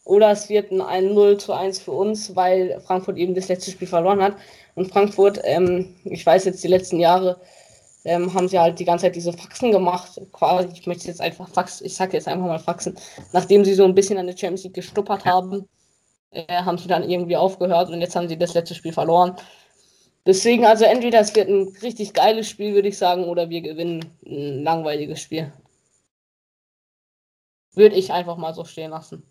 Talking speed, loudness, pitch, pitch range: 200 wpm, -20 LUFS, 180 Hz, 175-195 Hz